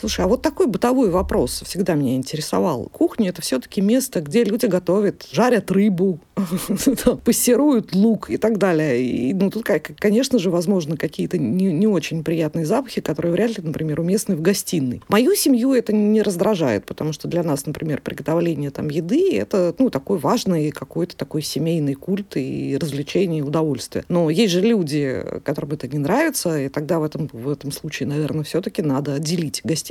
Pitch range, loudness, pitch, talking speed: 155-215 Hz, -20 LUFS, 180 Hz, 165 wpm